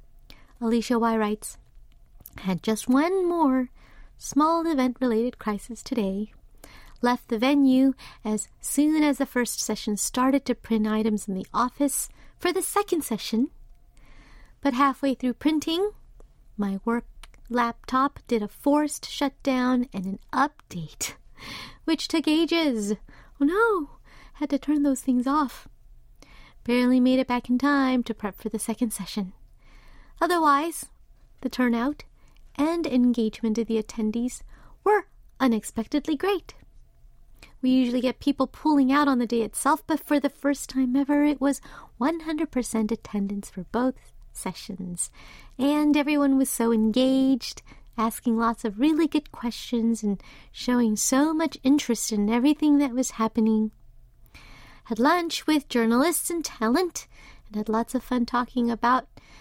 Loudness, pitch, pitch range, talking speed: -25 LUFS, 255 Hz, 225-290 Hz, 140 wpm